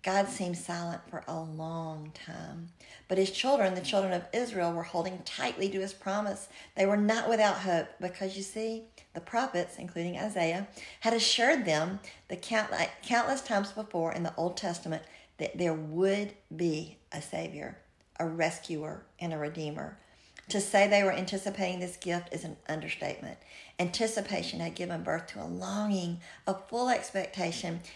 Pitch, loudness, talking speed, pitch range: 185 Hz, -32 LUFS, 160 wpm, 170-200 Hz